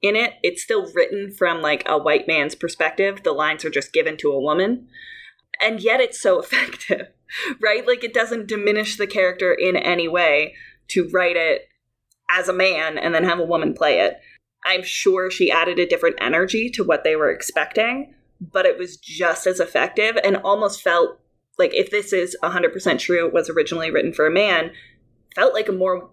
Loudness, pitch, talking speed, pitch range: -20 LUFS, 200 Hz, 195 wpm, 180-250 Hz